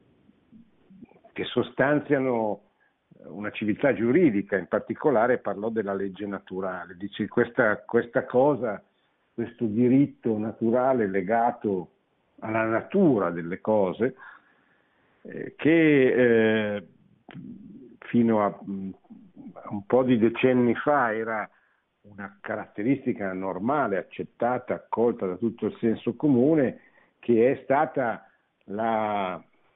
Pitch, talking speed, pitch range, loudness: 110 Hz, 95 wpm, 100-125 Hz, -25 LUFS